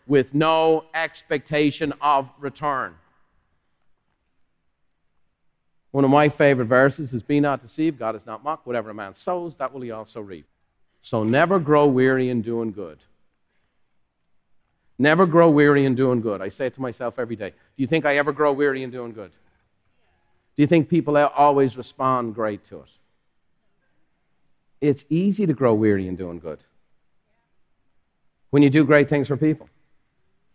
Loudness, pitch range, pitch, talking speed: -20 LUFS, 110-150 Hz, 135 Hz, 160 wpm